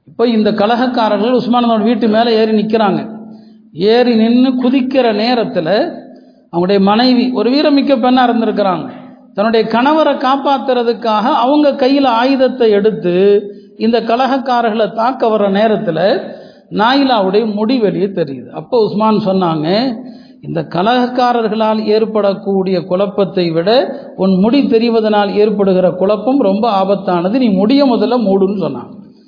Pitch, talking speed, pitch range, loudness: 225 Hz, 110 wpm, 205-245 Hz, -12 LUFS